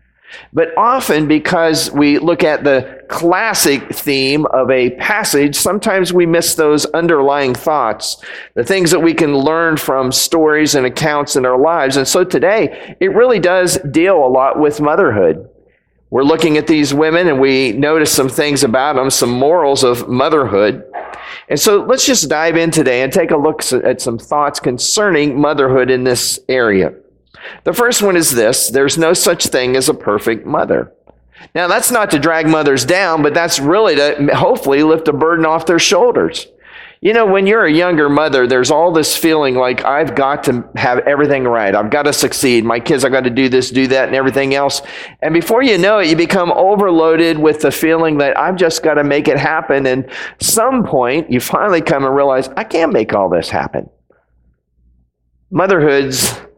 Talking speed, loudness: 185 wpm, -12 LUFS